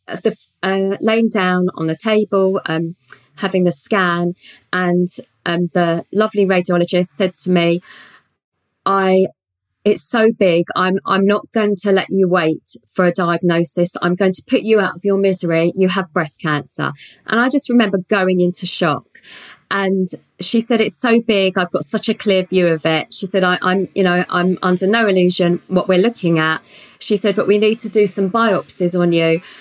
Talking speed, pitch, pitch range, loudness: 190 wpm, 185 Hz, 175-205 Hz, -16 LUFS